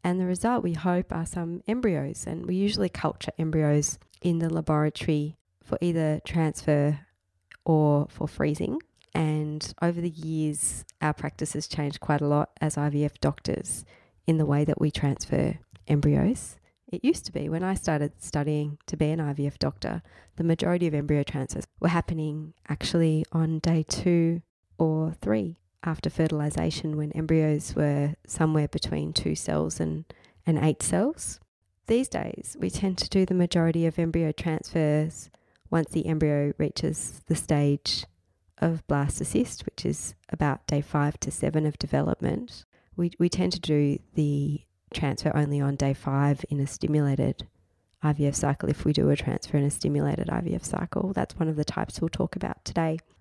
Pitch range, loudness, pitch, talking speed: 145-165 Hz, -27 LUFS, 155 Hz, 165 wpm